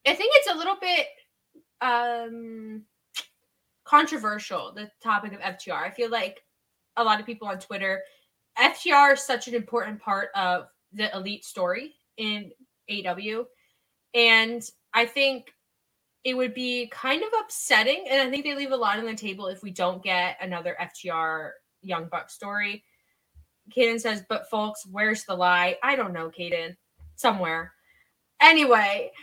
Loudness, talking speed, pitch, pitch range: -24 LUFS, 150 wpm, 215 Hz, 195-255 Hz